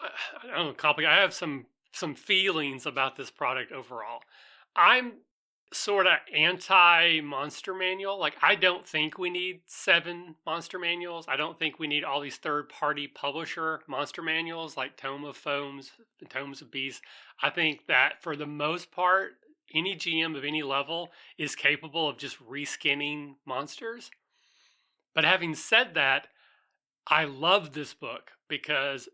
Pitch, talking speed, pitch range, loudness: 160 Hz, 155 wpm, 145-175 Hz, -27 LUFS